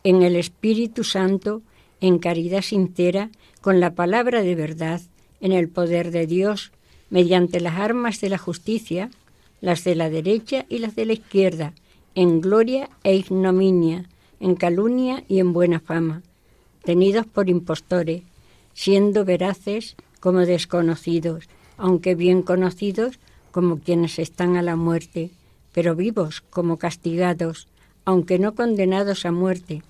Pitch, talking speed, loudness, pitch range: 180 Hz, 135 wpm, -21 LUFS, 170-200 Hz